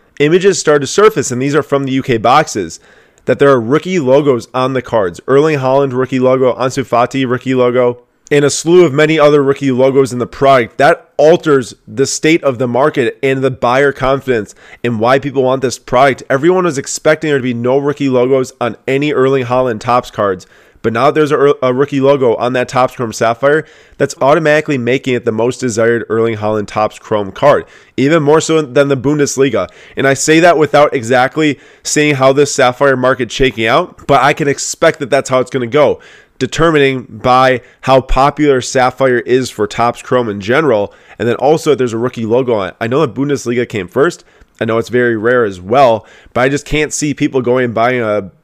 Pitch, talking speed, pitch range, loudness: 130 Hz, 210 wpm, 125-145 Hz, -12 LUFS